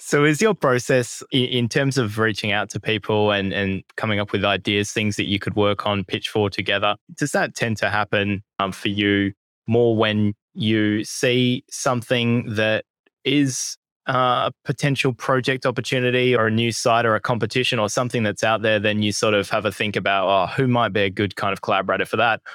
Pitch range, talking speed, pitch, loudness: 105-125 Hz, 200 wpm, 110 Hz, -21 LUFS